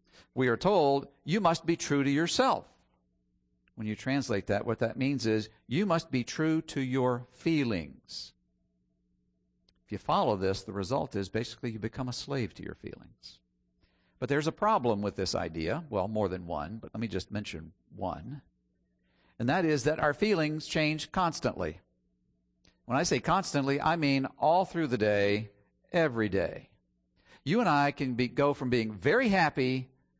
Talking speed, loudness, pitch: 170 wpm, -30 LUFS, 115 Hz